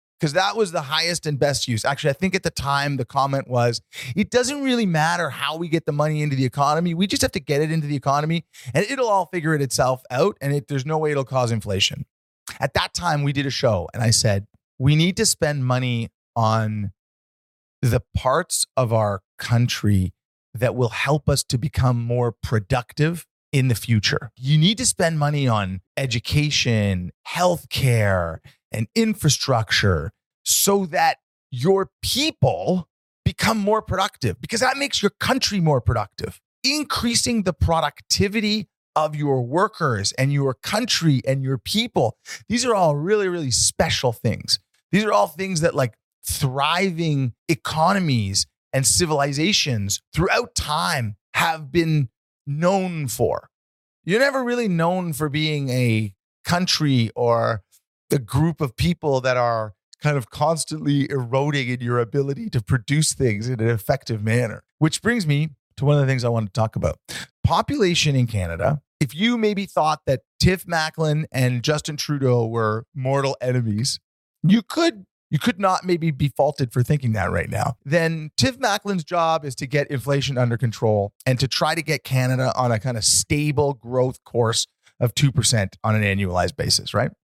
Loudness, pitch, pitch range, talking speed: -21 LUFS, 140 Hz, 120-165 Hz, 170 wpm